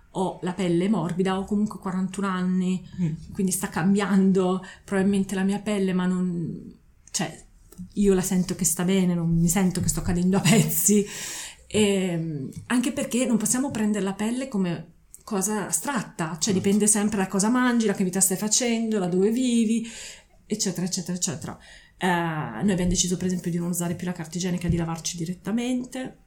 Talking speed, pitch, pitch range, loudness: 175 wpm, 190 Hz, 180-210 Hz, -24 LUFS